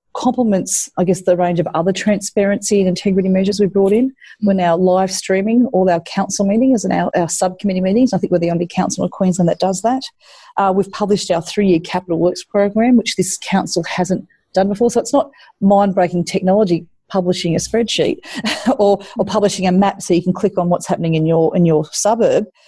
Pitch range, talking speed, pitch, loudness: 180-210 Hz, 210 wpm, 195 Hz, -16 LUFS